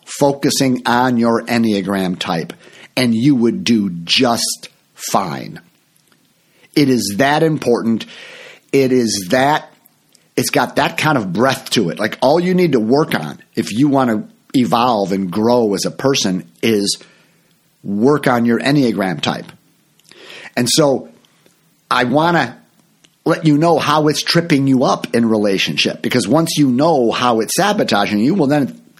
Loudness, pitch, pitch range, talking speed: -15 LUFS, 125 Hz, 115-145 Hz, 155 wpm